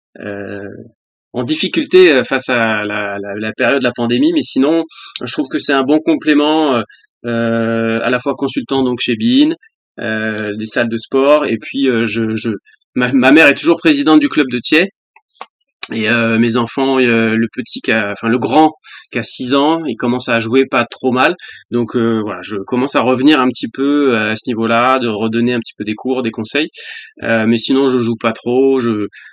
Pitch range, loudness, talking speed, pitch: 115-145 Hz, -14 LUFS, 210 wpm, 125 Hz